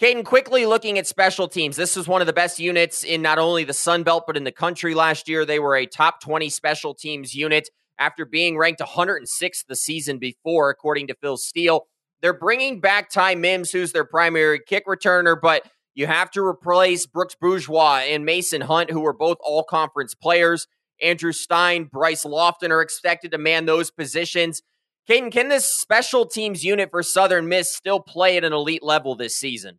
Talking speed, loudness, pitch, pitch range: 195 wpm, -20 LUFS, 170 Hz, 155-180 Hz